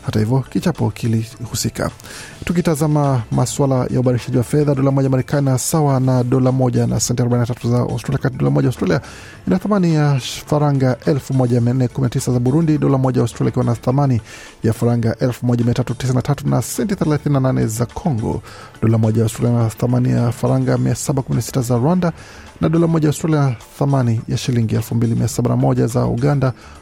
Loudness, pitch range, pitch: -17 LUFS, 120-140 Hz, 125 Hz